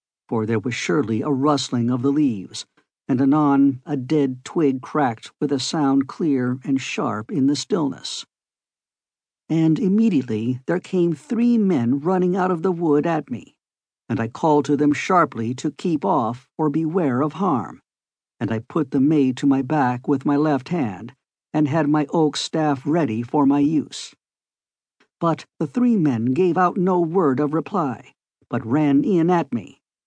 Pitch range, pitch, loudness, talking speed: 135-165 Hz, 145 Hz, -21 LUFS, 170 wpm